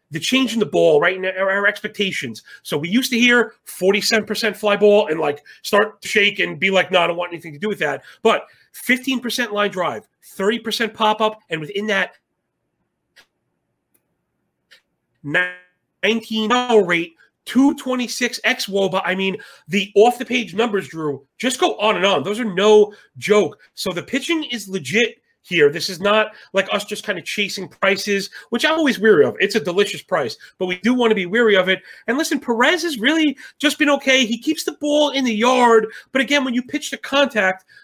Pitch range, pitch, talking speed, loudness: 195-245 Hz, 215 Hz, 190 wpm, -18 LUFS